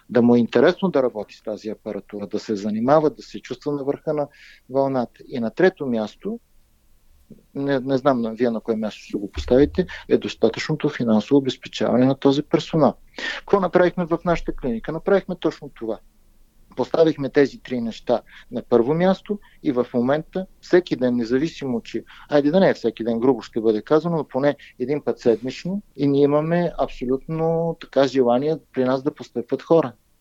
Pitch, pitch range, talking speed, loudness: 135 Hz, 115-160 Hz, 175 wpm, -22 LUFS